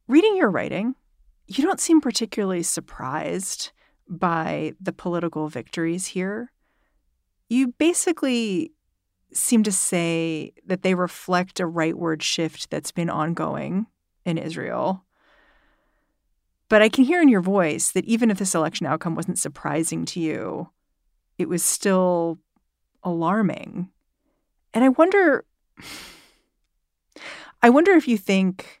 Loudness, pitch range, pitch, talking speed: -22 LUFS, 170-245 Hz, 190 Hz, 120 wpm